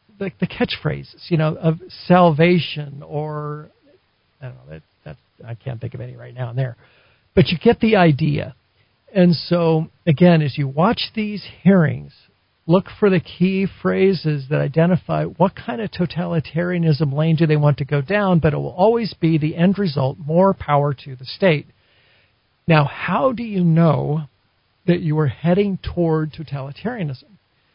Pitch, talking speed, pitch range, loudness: 160 Hz, 165 wpm, 140-180 Hz, -19 LUFS